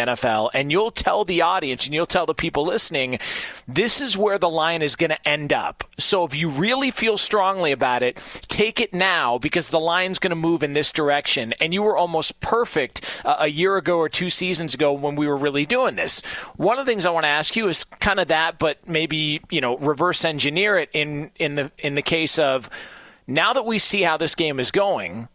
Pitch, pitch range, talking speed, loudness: 165 Hz, 150-190 Hz, 230 wpm, -20 LUFS